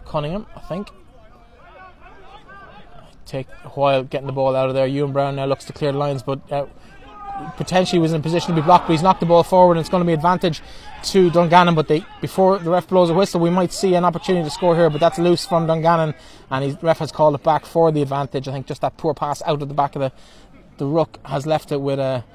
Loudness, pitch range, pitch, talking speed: -18 LUFS, 140-175 Hz, 160 Hz, 250 wpm